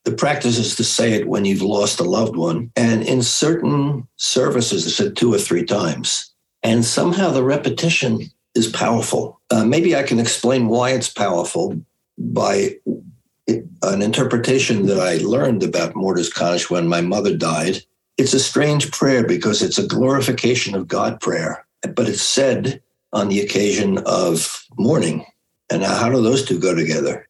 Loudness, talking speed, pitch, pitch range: -18 LUFS, 165 wpm, 120 Hz, 105-135 Hz